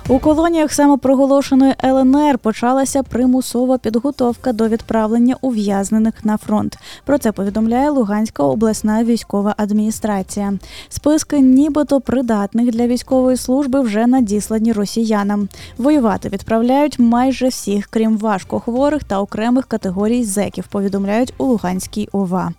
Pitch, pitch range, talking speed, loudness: 235 Hz, 210-260 Hz, 110 wpm, -16 LUFS